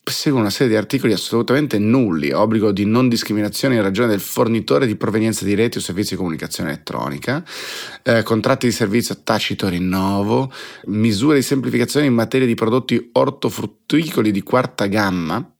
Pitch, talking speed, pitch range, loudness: 110 Hz, 160 wpm, 100-125 Hz, -18 LUFS